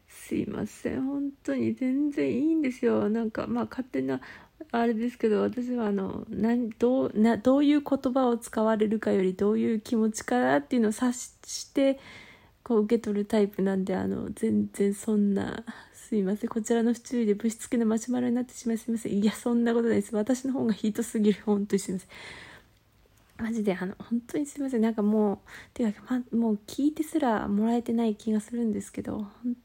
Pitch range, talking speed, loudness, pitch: 210-245 Hz, 410 characters per minute, -28 LUFS, 230 Hz